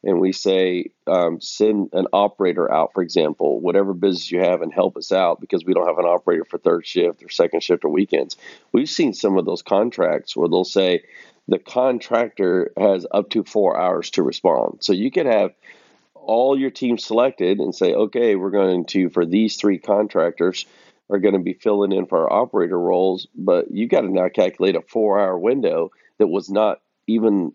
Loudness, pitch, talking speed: -19 LUFS, 120 Hz, 200 wpm